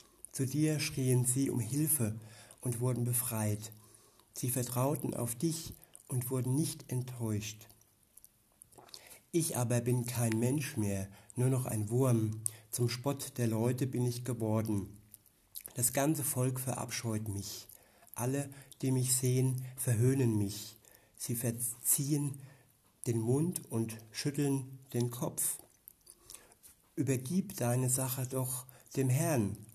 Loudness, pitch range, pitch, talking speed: -34 LUFS, 110-135 Hz, 125 Hz, 120 wpm